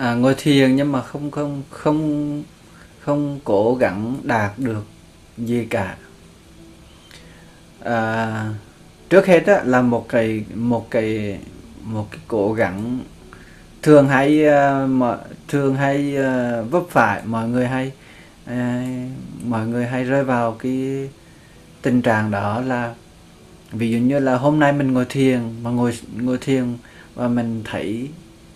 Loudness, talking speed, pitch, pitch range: -19 LUFS, 130 wpm, 125 Hz, 115-140 Hz